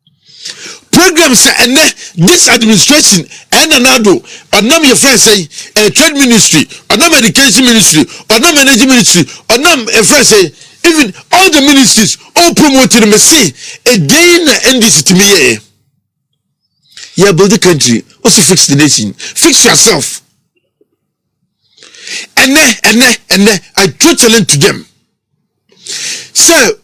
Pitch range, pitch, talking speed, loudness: 190-290 Hz, 230 Hz, 130 wpm, -4 LUFS